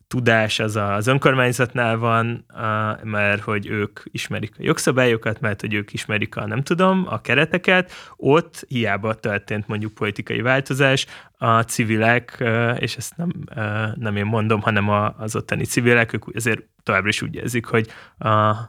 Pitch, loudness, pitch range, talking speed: 115 Hz, -20 LUFS, 110-125 Hz, 150 wpm